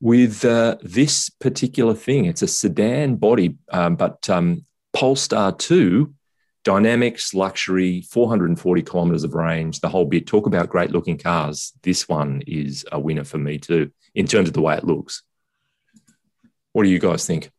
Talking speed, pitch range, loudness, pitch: 165 wpm, 85-130 Hz, -20 LUFS, 100 Hz